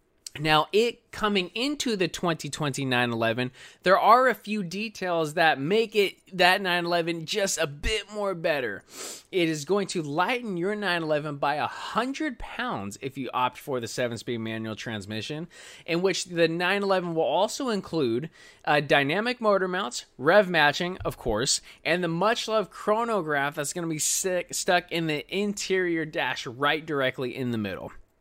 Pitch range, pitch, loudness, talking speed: 145-200 Hz, 175 Hz, -26 LUFS, 160 wpm